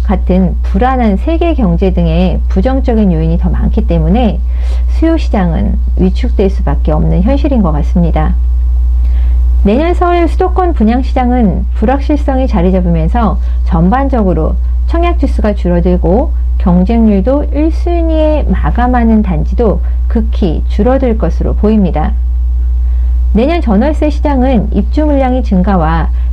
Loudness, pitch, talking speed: -11 LUFS, 180 Hz, 285 characters per minute